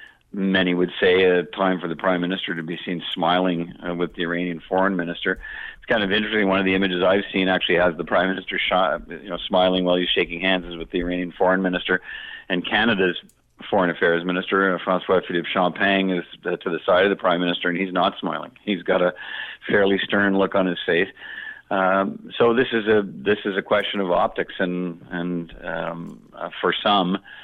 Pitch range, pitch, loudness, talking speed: 90-95 Hz, 90 Hz, -22 LUFS, 210 wpm